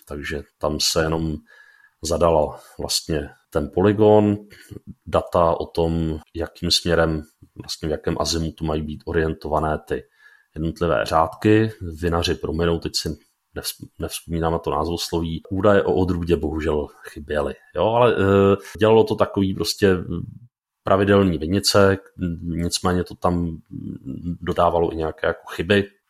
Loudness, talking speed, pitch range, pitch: -21 LUFS, 125 wpm, 80-100 Hz, 85 Hz